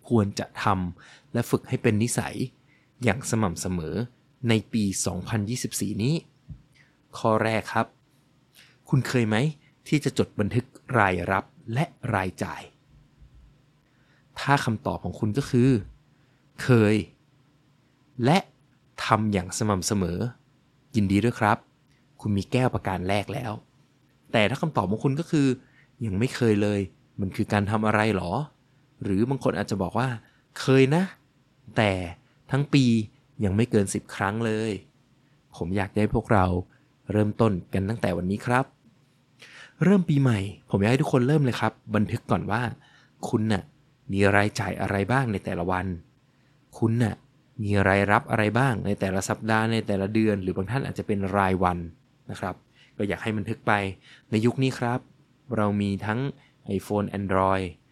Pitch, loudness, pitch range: 115 Hz, -26 LUFS, 100-135 Hz